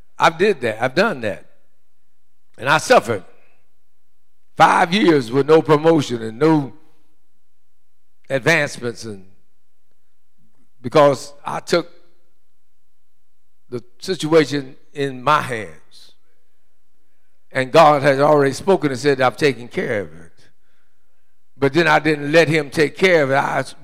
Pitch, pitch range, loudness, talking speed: 145 Hz, 130-160 Hz, -17 LUFS, 125 wpm